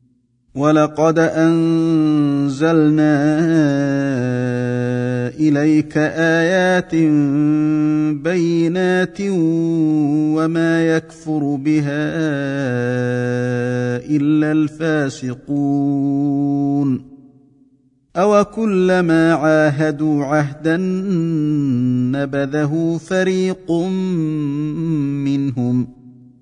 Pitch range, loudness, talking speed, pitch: 140-165 Hz, -17 LUFS, 40 wpm, 150 Hz